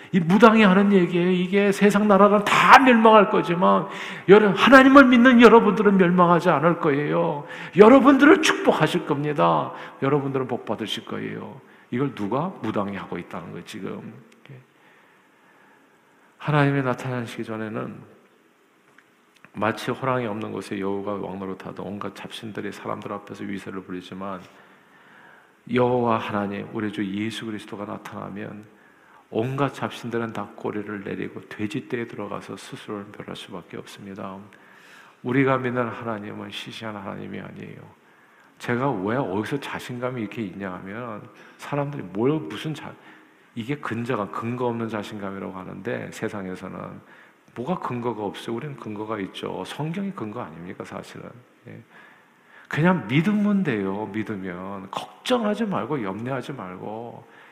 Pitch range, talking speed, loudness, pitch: 105-170 Hz, 315 characters per minute, -21 LUFS, 120 Hz